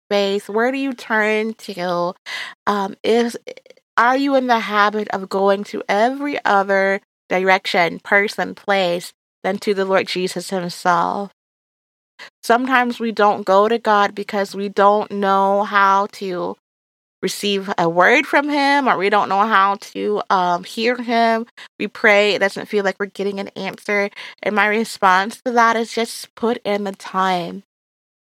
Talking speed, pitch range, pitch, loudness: 155 wpm, 195-230 Hz, 200 Hz, -18 LUFS